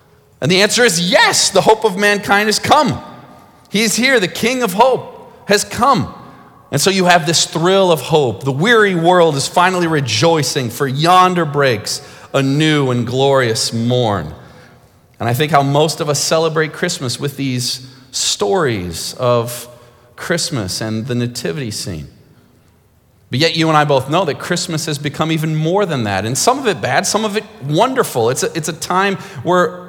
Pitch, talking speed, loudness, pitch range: 155 Hz, 180 wpm, -14 LUFS, 130-185 Hz